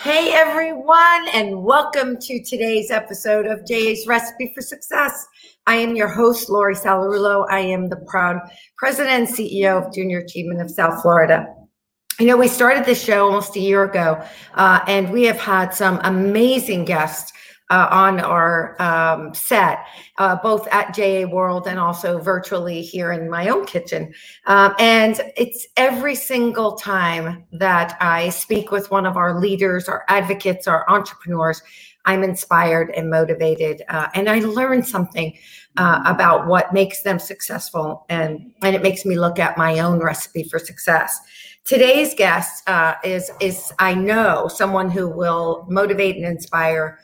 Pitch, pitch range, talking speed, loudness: 195 Hz, 175-225 Hz, 160 wpm, -17 LUFS